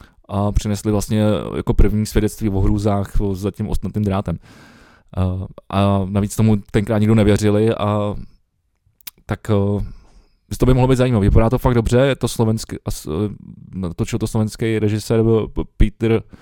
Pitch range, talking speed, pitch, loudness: 100-110 Hz, 140 wpm, 105 Hz, -19 LUFS